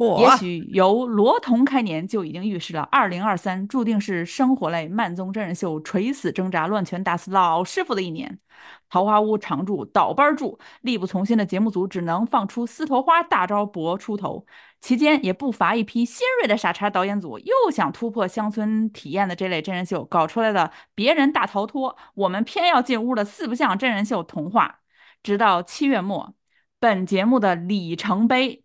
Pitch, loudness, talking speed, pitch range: 210 Hz, -22 LUFS, 285 characters per minute, 185-250 Hz